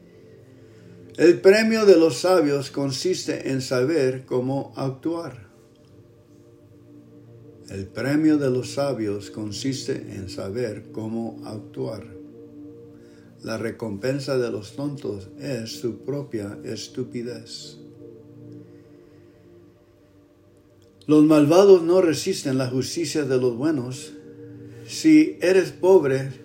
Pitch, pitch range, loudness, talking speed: 130 Hz, 110-150 Hz, -22 LUFS, 95 wpm